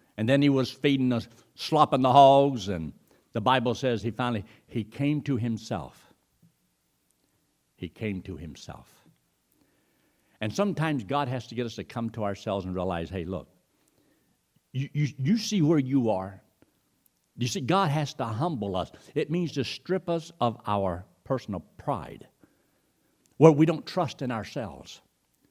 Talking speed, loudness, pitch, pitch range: 160 wpm, -27 LUFS, 125 Hz, 100-145 Hz